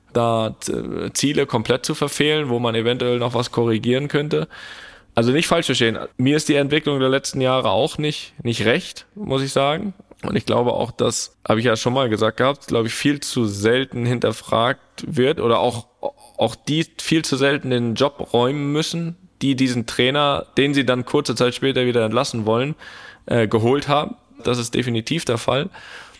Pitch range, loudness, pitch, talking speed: 120-145 Hz, -20 LUFS, 130 Hz, 185 wpm